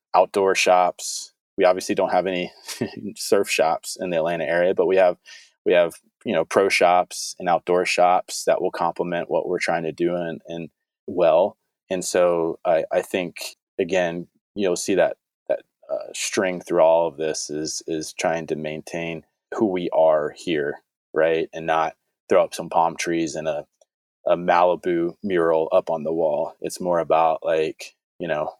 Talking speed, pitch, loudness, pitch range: 175 wpm, 85 Hz, -22 LUFS, 80-90 Hz